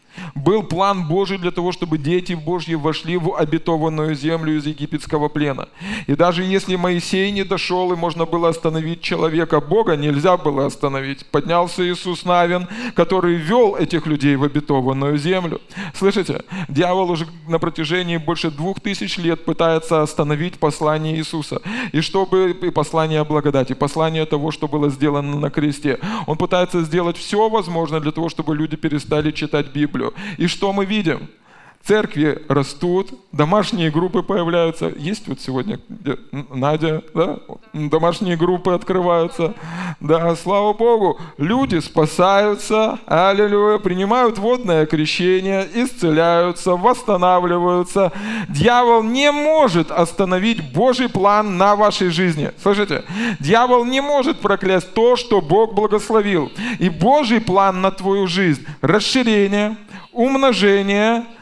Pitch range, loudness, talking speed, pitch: 160-200 Hz, -18 LUFS, 130 wpm, 175 Hz